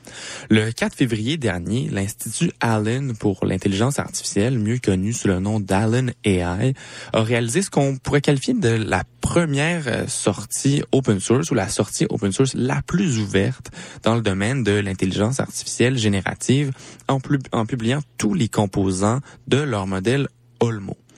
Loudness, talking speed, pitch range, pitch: -21 LUFS, 155 wpm, 105-135 Hz, 115 Hz